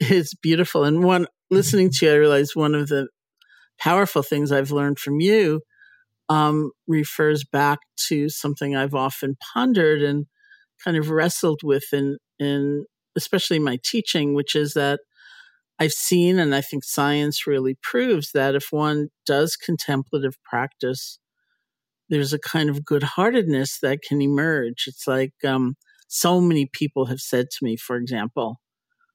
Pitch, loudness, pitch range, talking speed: 145 Hz, -21 LUFS, 140-160 Hz, 150 wpm